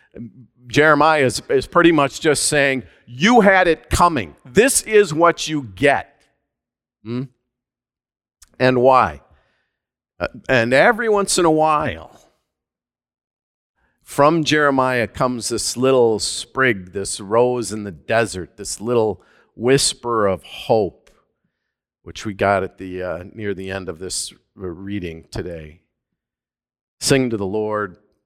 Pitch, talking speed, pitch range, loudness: 120 Hz, 125 wpm, 100-145 Hz, -18 LUFS